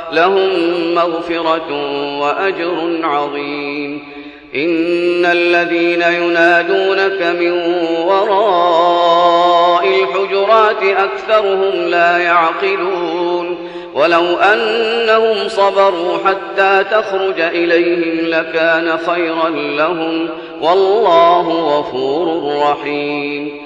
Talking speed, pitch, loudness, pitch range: 65 wpm, 170 Hz, -13 LUFS, 165-195 Hz